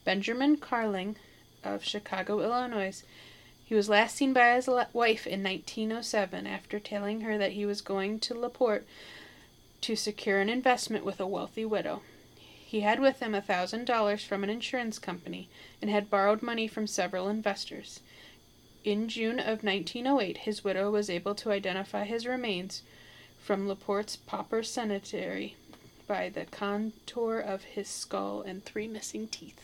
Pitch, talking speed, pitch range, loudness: 210 Hz, 150 wpm, 195-230 Hz, -31 LUFS